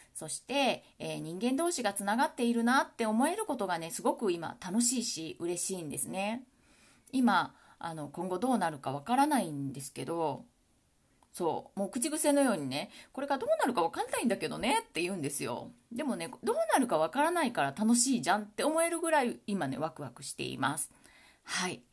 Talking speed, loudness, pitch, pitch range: 385 characters per minute, -32 LUFS, 230 Hz, 170-280 Hz